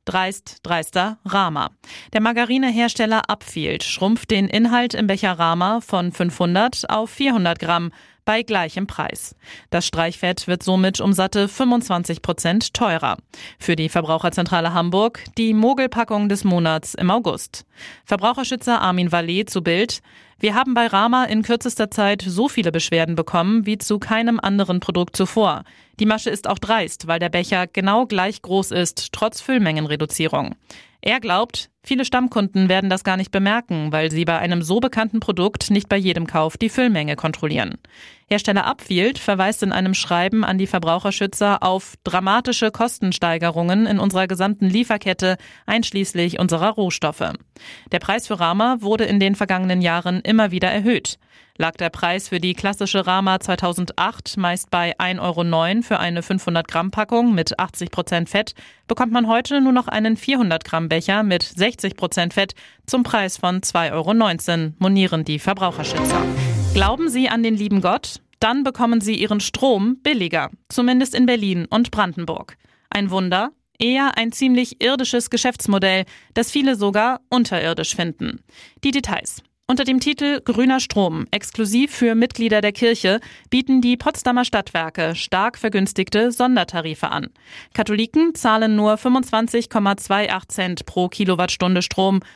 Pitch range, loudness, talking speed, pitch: 180-230 Hz, -19 LUFS, 145 wpm, 200 Hz